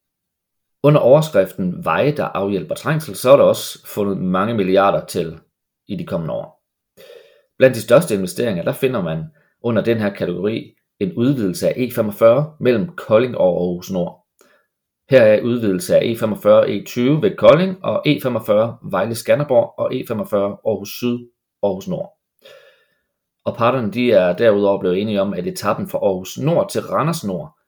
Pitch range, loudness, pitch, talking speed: 100-145 Hz, -17 LUFS, 120 Hz, 160 wpm